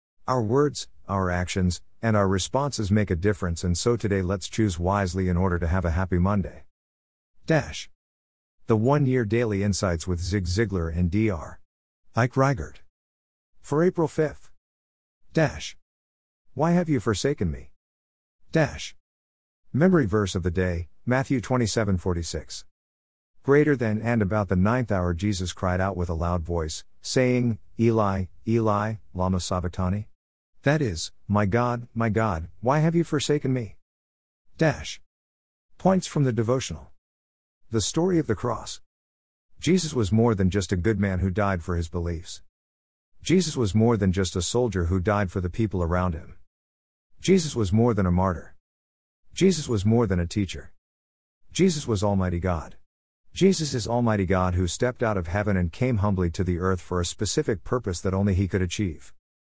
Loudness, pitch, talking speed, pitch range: -25 LUFS, 95 Hz, 160 wpm, 85-115 Hz